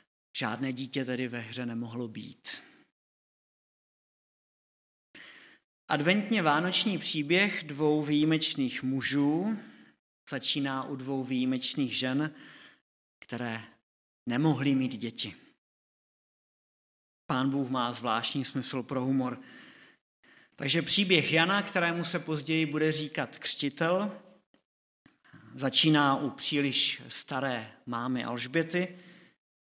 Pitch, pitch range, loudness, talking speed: 140 Hz, 130-160 Hz, -29 LUFS, 90 wpm